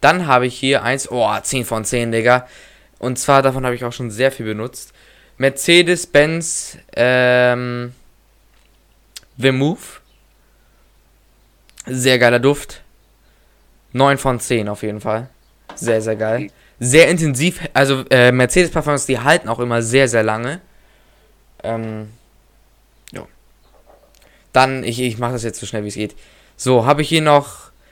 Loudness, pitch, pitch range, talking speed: -16 LUFS, 125 Hz, 115-140 Hz, 140 wpm